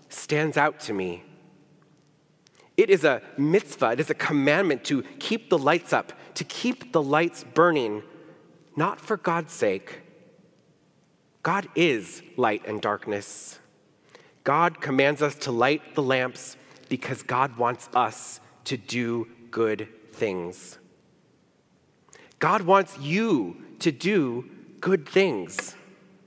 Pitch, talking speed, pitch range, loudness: 150 Hz, 120 wpm, 125-170 Hz, -25 LUFS